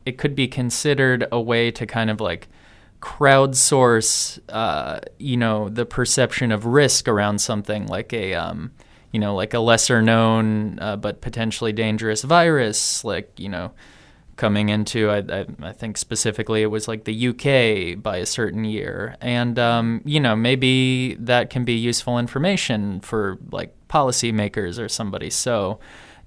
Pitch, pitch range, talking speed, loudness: 115 Hz, 110-125 Hz, 160 wpm, -20 LUFS